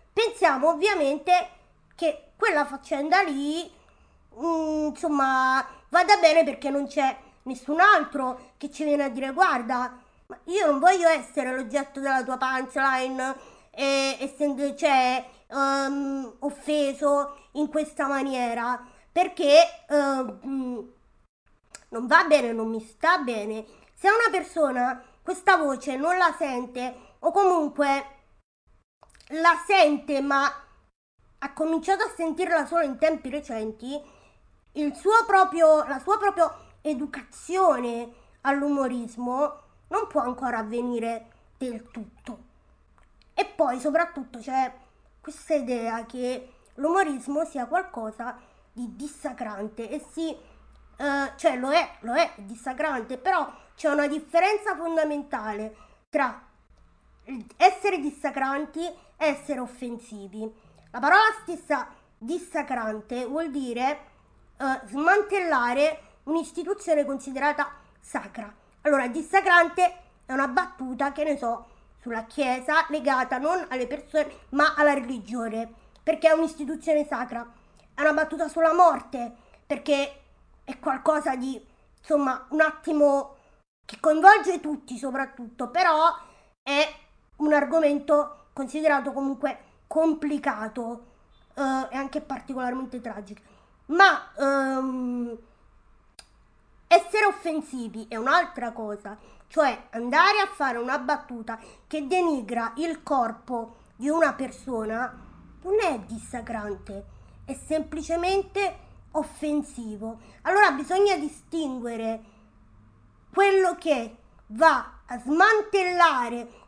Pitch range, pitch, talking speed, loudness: 250-320 Hz, 285 Hz, 105 wpm, -25 LUFS